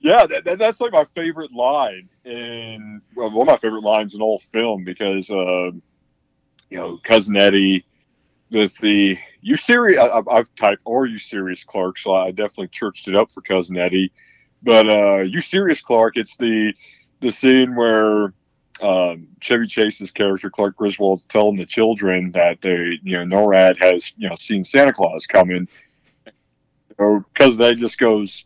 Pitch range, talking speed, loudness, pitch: 95-115 Hz, 175 wpm, -17 LUFS, 105 Hz